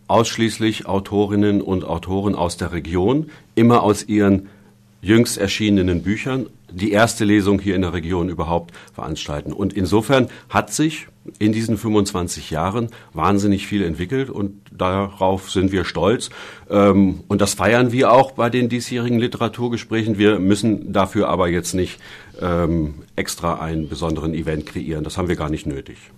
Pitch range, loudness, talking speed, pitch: 90-110 Hz, -19 LUFS, 145 wpm, 100 Hz